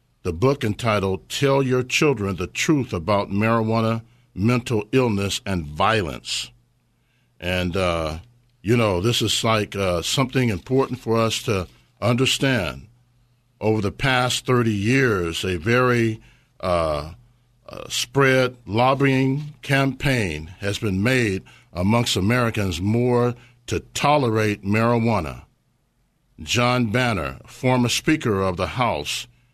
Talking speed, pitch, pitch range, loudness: 115 wpm, 115 Hz, 100-125 Hz, -21 LUFS